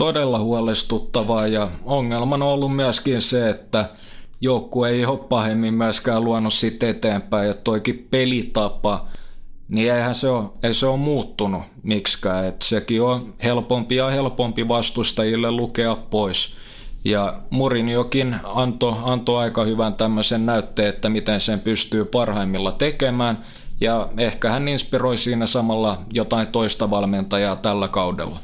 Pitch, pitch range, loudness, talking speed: 115 Hz, 105-125 Hz, -21 LUFS, 135 wpm